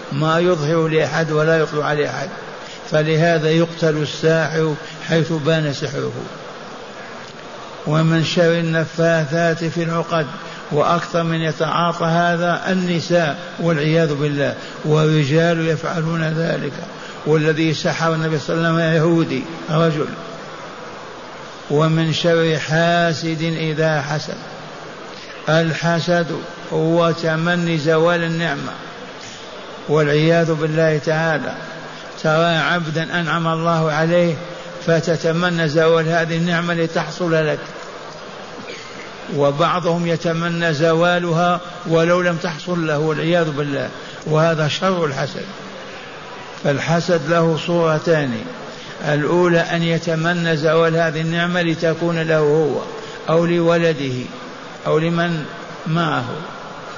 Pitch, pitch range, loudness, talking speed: 165 Hz, 155-170 Hz, -18 LUFS, 95 wpm